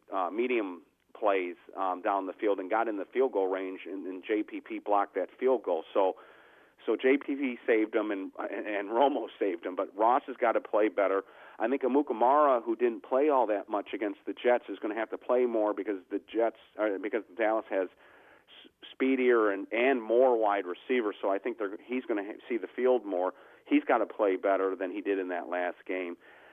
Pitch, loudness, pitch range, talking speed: 105 Hz, -30 LUFS, 95-130 Hz, 210 wpm